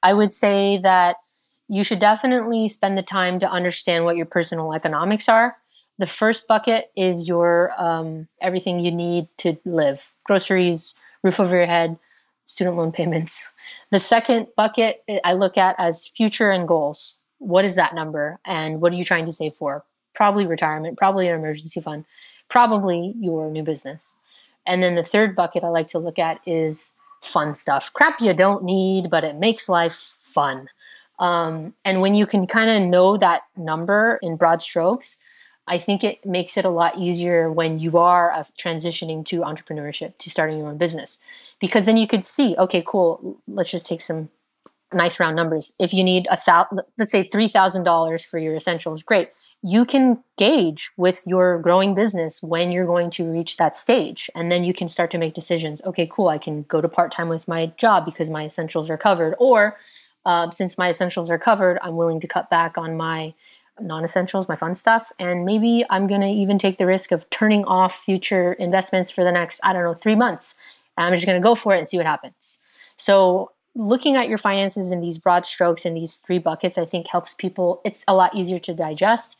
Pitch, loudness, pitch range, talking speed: 180 Hz, -20 LUFS, 170-200 Hz, 200 wpm